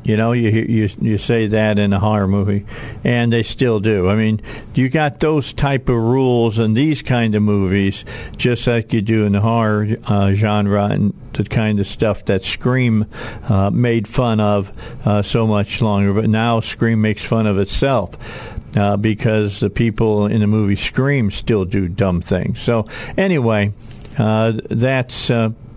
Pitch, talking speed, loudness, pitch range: 110 Hz, 175 wpm, -17 LUFS, 105-120 Hz